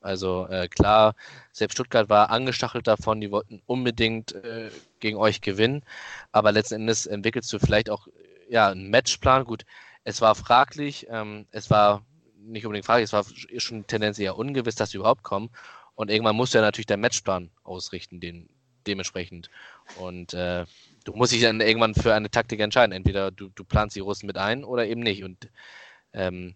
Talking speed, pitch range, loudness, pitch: 180 wpm, 100-115 Hz, -24 LUFS, 105 Hz